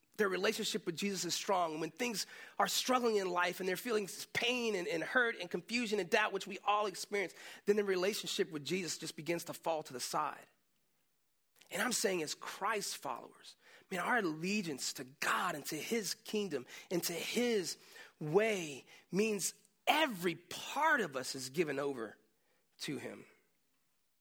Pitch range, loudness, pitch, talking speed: 170-215 Hz, -36 LUFS, 195 Hz, 170 wpm